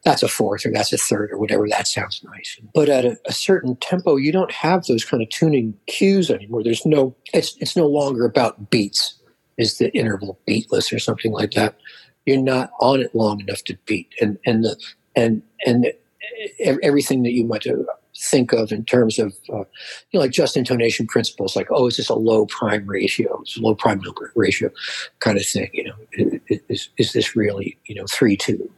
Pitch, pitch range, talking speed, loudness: 120 Hz, 110-140 Hz, 205 wpm, -20 LUFS